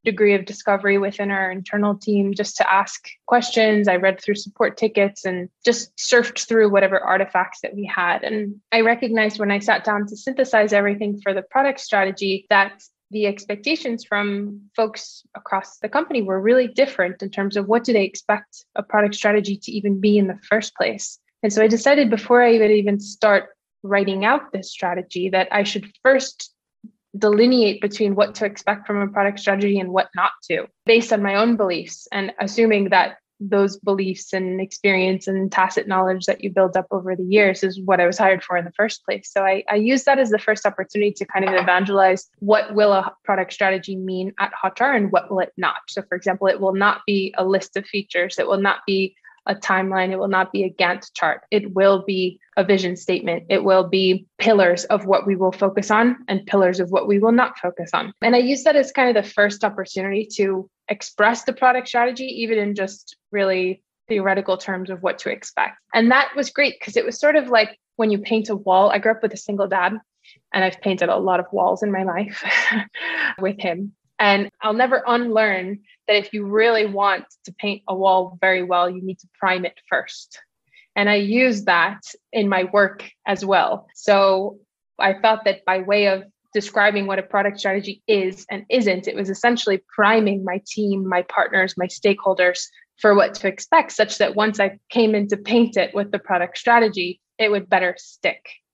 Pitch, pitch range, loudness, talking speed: 200 Hz, 190-215 Hz, -19 LUFS, 205 wpm